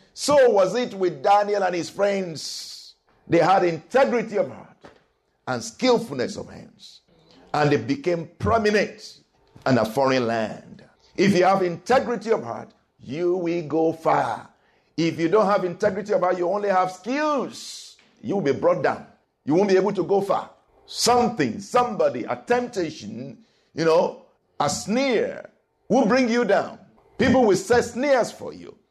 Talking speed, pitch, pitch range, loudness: 160 wpm, 195 Hz, 170-240 Hz, -22 LUFS